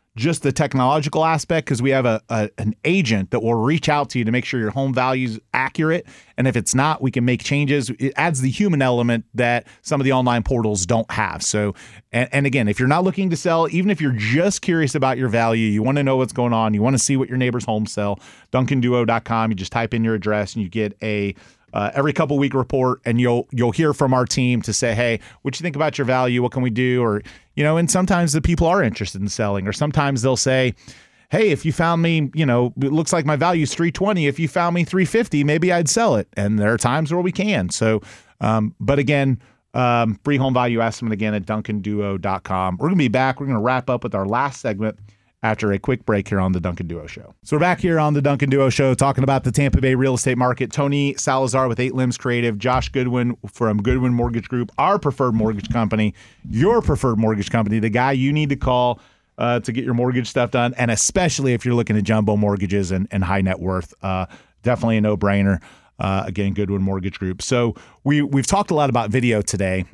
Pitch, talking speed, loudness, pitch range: 125 Hz, 235 wpm, -20 LUFS, 110-140 Hz